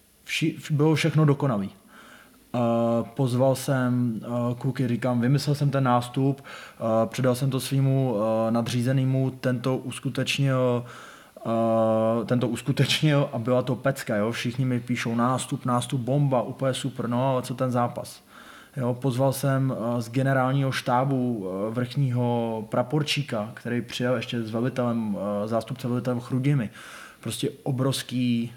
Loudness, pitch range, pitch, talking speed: -25 LUFS, 120-135 Hz, 125 Hz, 135 wpm